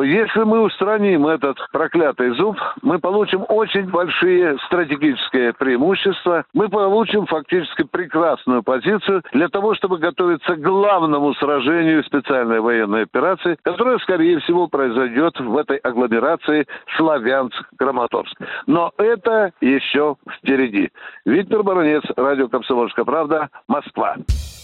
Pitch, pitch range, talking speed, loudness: 170 Hz, 135-205 Hz, 110 wpm, -18 LUFS